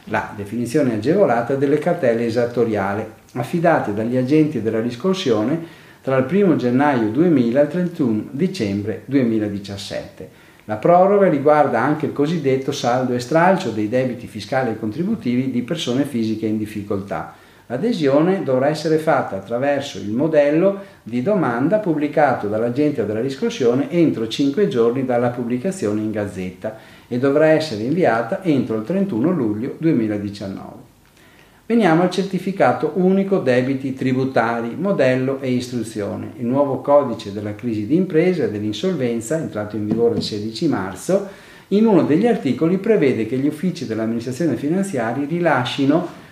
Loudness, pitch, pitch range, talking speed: -19 LUFS, 130 Hz, 110-160 Hz, 135 wpm